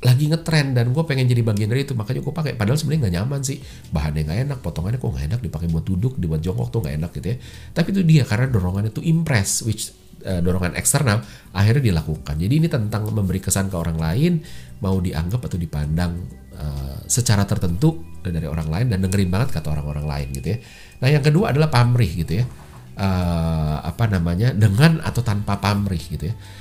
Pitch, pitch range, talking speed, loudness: 100 Hz, 85-125 Hz, 200 wpm, -21 LUFS